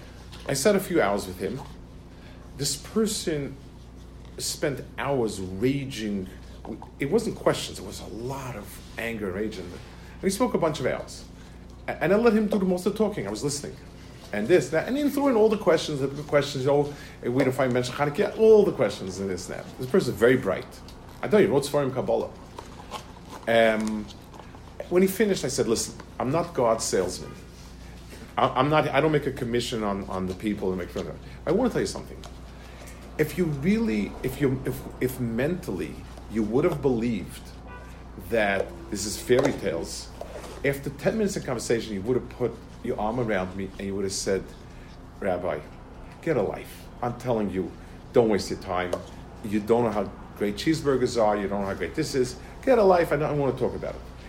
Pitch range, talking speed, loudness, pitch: 100-150 Hz, 200 wpm, -26 LUFS, 125 Hz